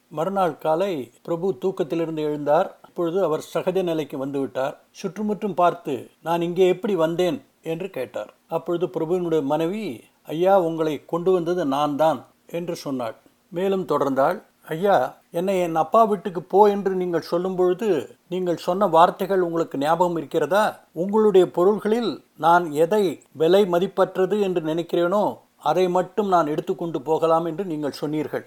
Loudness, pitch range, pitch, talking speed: -22 LUFS, 160-190 Hz, 175 Hz, 135 wpm